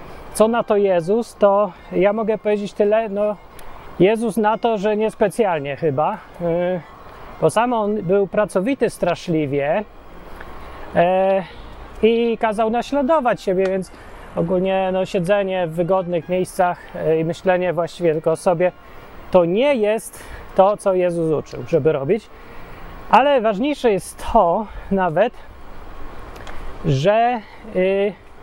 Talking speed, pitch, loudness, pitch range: 115 wpm, 195 Hz, -19 LUFS, 180-220 Hz